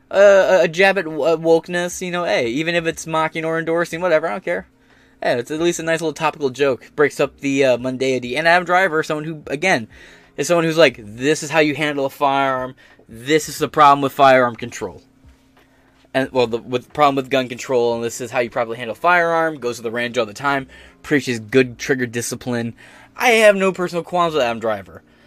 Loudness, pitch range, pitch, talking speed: -18 LUFS, 125-165 Hz, 145 Hz, 225 wpm